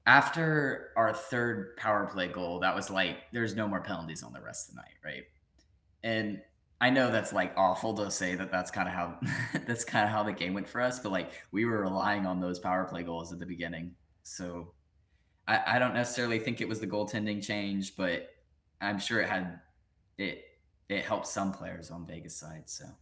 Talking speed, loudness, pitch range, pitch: 210 wpm, -30 LUFS, 85-105 Hz, 95 Hz